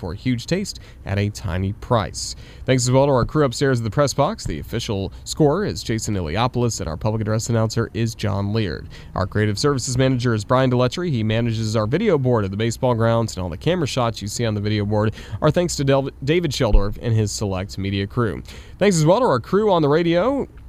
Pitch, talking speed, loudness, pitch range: 115 Hz, 230 wpm, -21 LUFS, 105-135 Hz